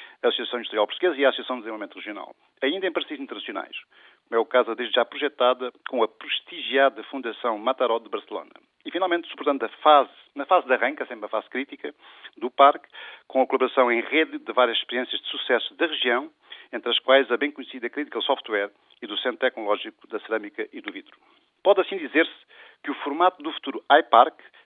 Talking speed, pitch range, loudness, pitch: 195 wpm, 120-145 Hz, -24 LUFS, 130 Hz